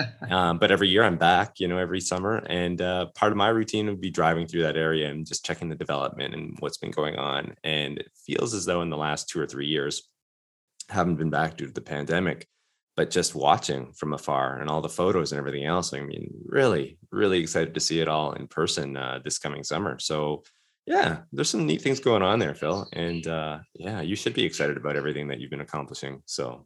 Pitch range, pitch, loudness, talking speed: 75-90 Hz, 80 Hz, -26 LUFS, 230 wpm